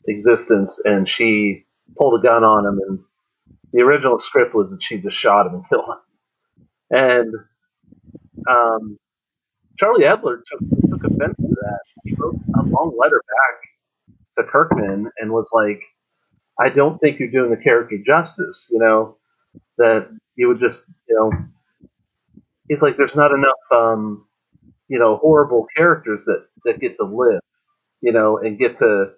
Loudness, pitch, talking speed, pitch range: -17 LUFS, 120 Hz, 160 wpm, 110-170 Hz